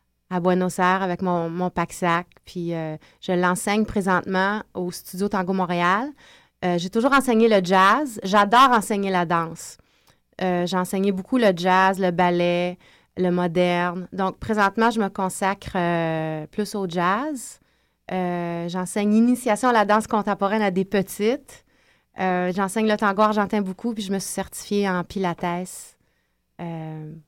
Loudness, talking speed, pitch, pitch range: -22 LUFS, 150 wpm, 185 Hz, 175-205 Hz